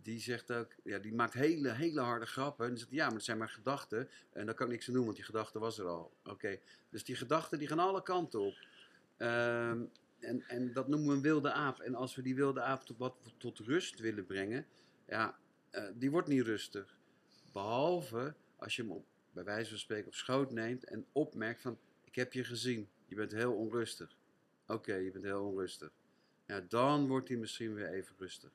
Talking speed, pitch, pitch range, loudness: 220 wpm, 120 Hz, 110-130 Hz, -38 LUFS